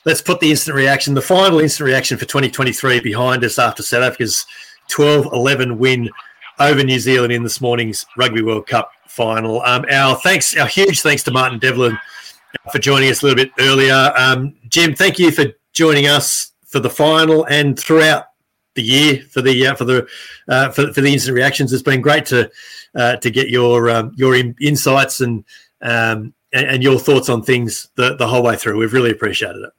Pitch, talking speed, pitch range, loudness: 130 Hz, 195 wpm, 120-145 Hz, -14 LUFS